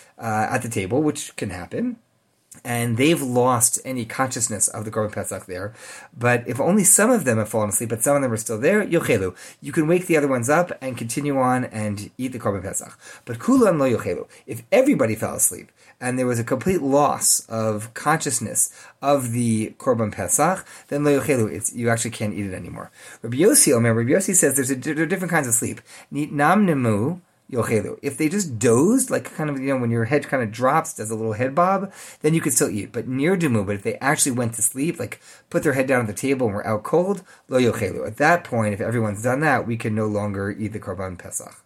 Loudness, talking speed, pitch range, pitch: -21 LUFS, 230 wpm, 110-150 Hz, 125 Hz